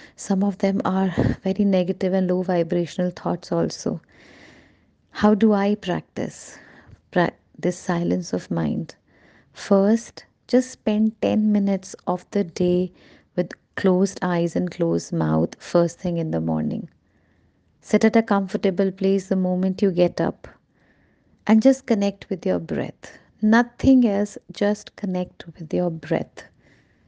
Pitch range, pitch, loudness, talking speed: 170-205 Hz, 185 Hz, -22 LUFS, 135 wpm